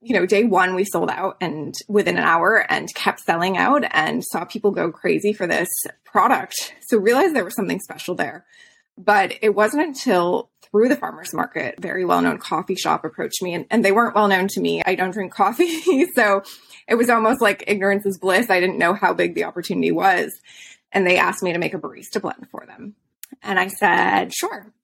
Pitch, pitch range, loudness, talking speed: 205 Hz, 185-230 Hz, -19 LUFS, 210 wpm